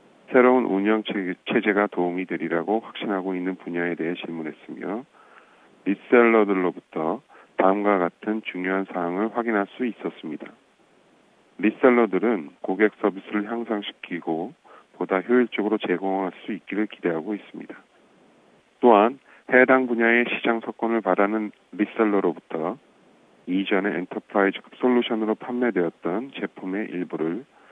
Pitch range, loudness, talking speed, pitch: 95-115 Hz, -23 LUFS, 310 characters per minute, 105 Hz